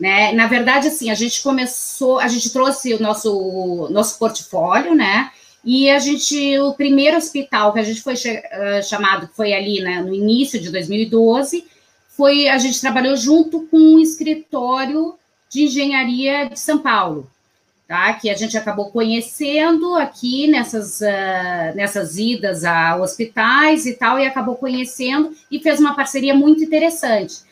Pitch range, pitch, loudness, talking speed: 210-285 Hz, 255 Hz, -16 LUFS, 160 wpm